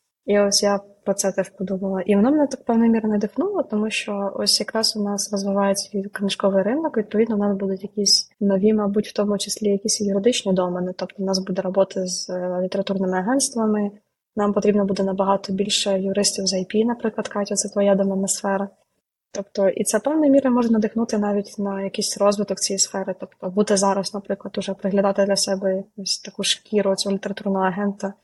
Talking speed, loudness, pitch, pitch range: 180 wpm, -21 LUFS, 200 Hz, 195-210 Hz